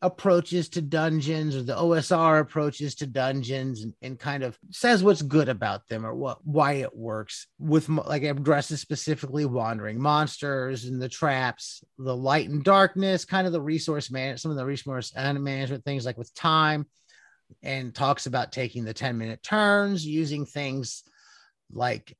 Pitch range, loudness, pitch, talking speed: 130-155 Hz, -26 LUFS, 145 Hz, 170 wpm